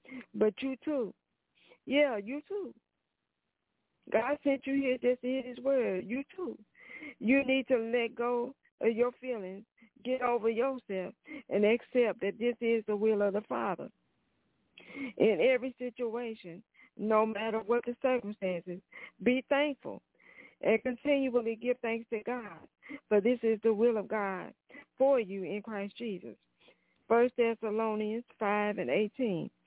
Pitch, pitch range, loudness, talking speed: 240 Hz, 215-260 Hz, -32 LUFS, 145 wpm